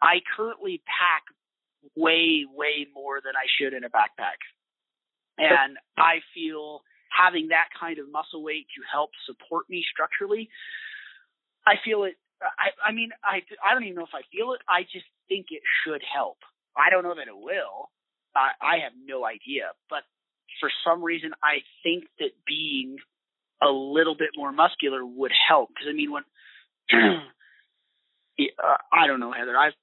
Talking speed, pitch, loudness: 165 wpm, 170 Hz, -24 LUFS